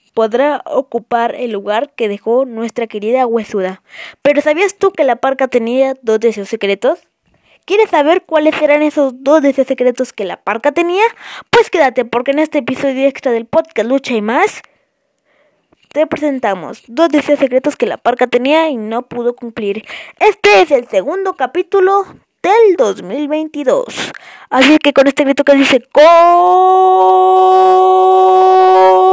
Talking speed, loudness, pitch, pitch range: 150 wpm, -12 LUFS, 280 Hz, 235-325 Hz